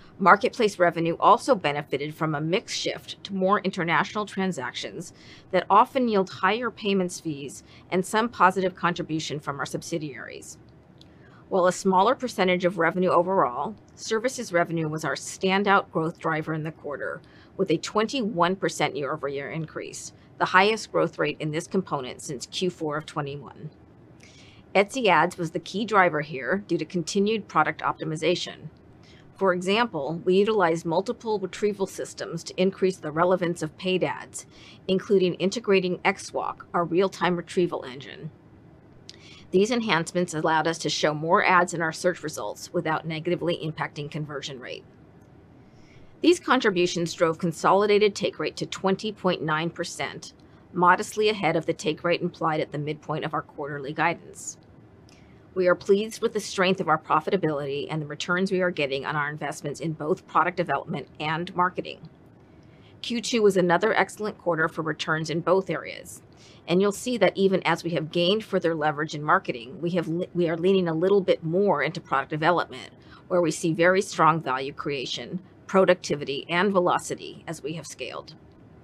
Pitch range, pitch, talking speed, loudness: 160-190 Hz, 175 Hz, 155 wpm, -25 LUFS